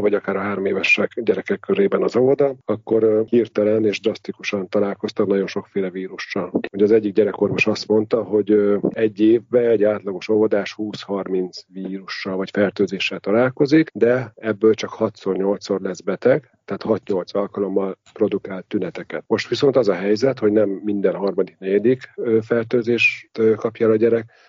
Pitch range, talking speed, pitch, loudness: 100-115 Hz, 145 wpm, 105 Hz, -20 LUFS